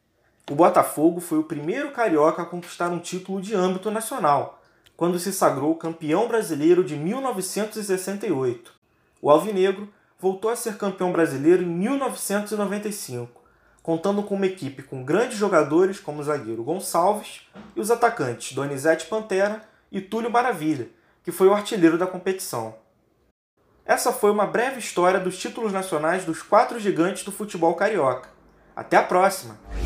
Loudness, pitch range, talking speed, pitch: -23 LUFS, 160-210 Hz, 145 wpm, 185 Hz